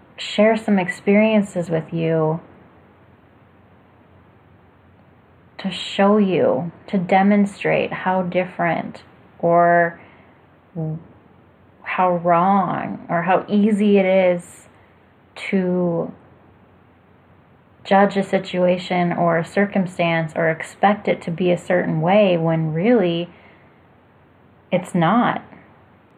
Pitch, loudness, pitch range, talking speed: 180 Hz, -19 LUFS, 165-195 Hz, 90 wpm